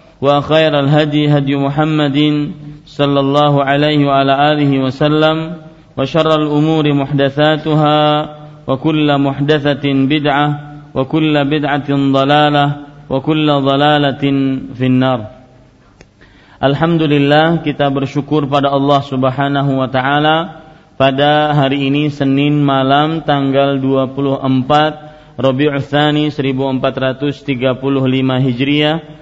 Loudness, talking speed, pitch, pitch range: -13 LUFS, 75 wpm, 145 Hz, 135-150 Hz